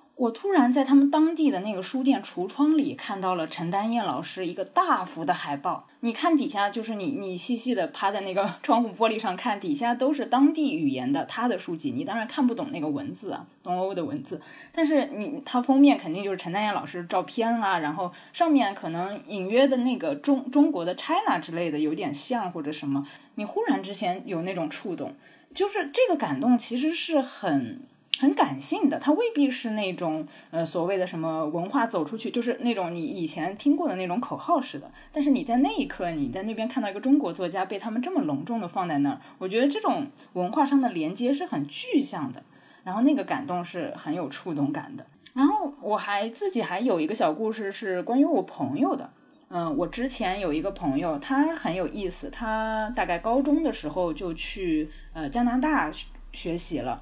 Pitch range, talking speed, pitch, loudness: 185-285 Hz, 315 characters per minute, 240 Hz, -27 LUFS